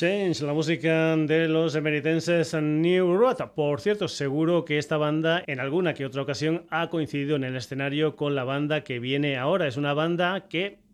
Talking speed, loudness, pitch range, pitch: 190 wpm, -25 LUFS, 145-170 Hz, 155 Hz